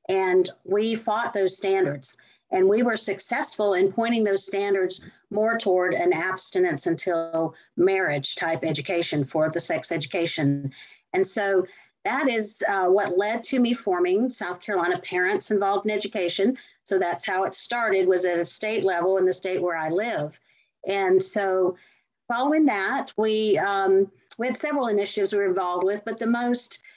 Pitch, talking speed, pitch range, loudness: 195 Hz, 165 wpm, 180-220 Hz, -24 LUFS